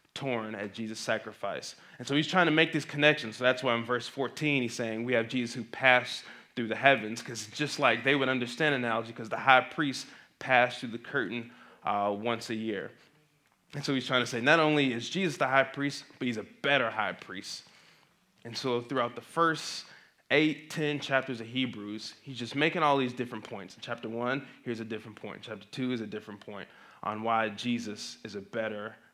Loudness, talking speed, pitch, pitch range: -30 LUFS, 210 wpm, 125 Hz, 115-140 Hz